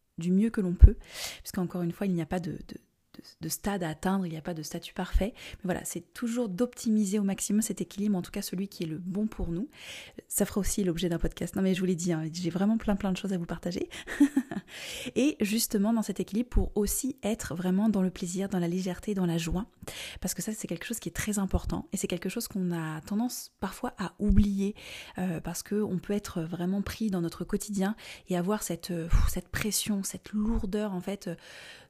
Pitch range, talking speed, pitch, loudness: 175-210 Hz, 235 wpm, 195 Hz, -31 LUFS